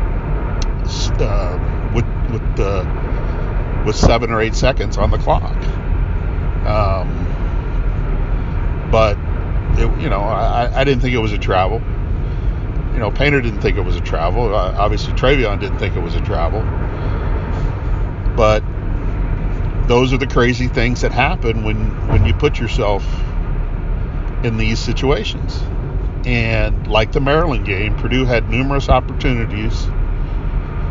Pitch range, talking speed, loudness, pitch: 90-115 Hz, 130 wpm, -18 LUFS, 105 Hz